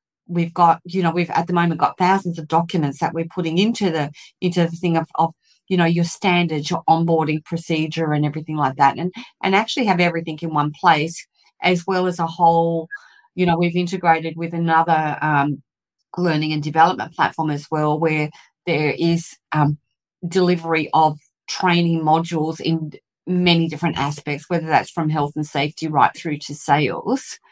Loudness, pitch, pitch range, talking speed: -20 LUFS, 165 Hz, 155-175 Hz, 175 wpm